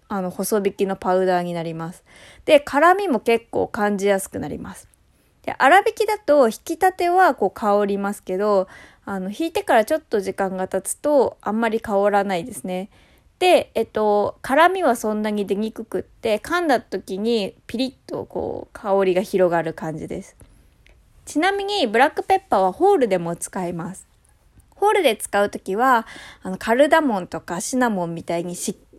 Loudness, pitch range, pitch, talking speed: -20 LUFS, 190-295 Hz, 210 Hz, 335 characters per minute